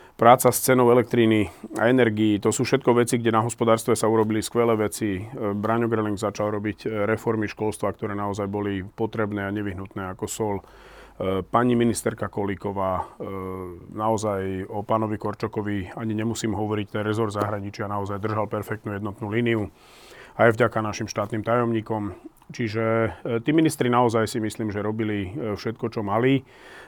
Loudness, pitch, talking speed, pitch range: -24 LUFS, 110 Hz, 145 wpm, 105-115 Hz